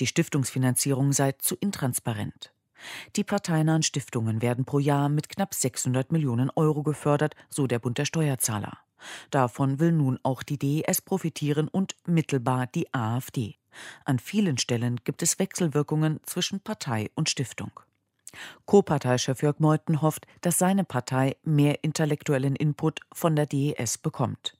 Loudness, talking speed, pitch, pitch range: -26 LUFS, 140 wpm, 145 Hz, 130-160 Hz